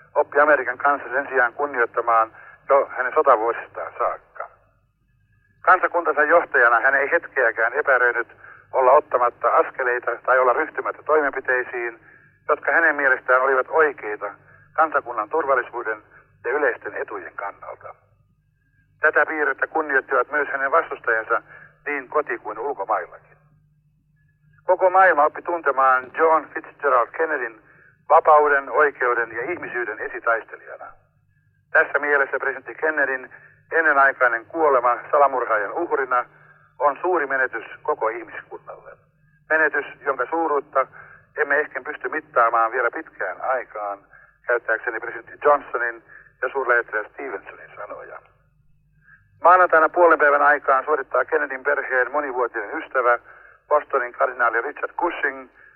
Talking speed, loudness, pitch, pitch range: 105 wpm, -20 LUFS, 135 Hz, 120-150 Hz